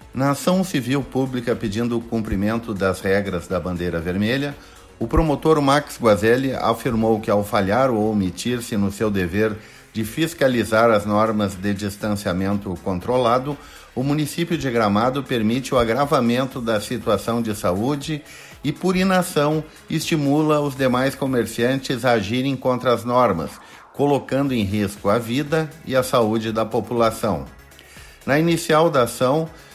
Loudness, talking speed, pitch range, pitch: -21 LUFS, 140 wpm, 105-140 Hz, 120 Hz